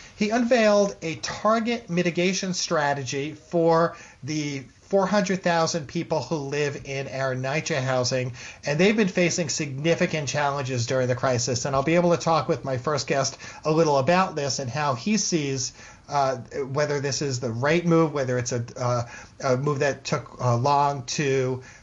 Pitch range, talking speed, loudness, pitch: 130-170 Hz, 170 wpm, -24 LUFS, 145 Hz